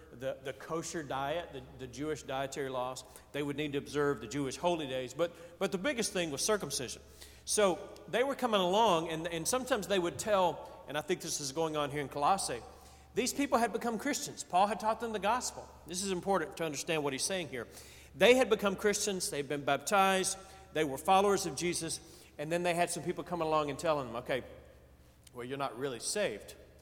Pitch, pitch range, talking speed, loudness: 170 Hz, 140-195 Hz, 215 wpm, -33 LUFS